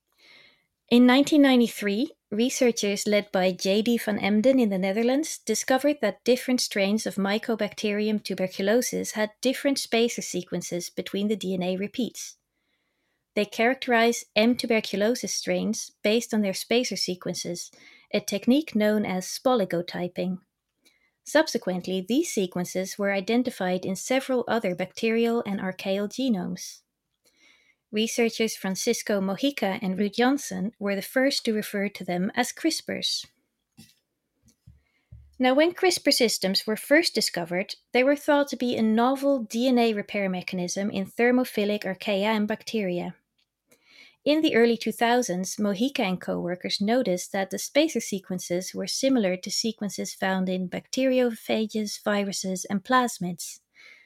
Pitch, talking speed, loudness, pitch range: 215 Hz, 125 wpm, -25 LUFS, 190-245 Hz